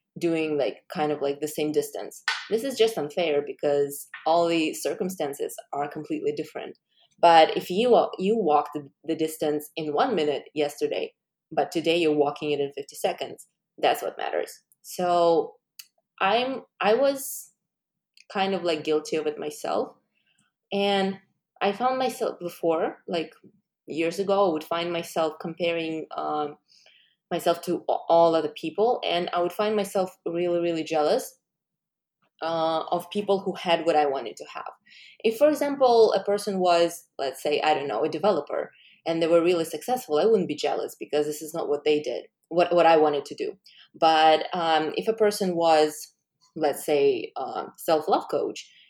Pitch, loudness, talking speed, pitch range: 170 Hz, -25 LUFS, 170 wpm, 155-205 Hz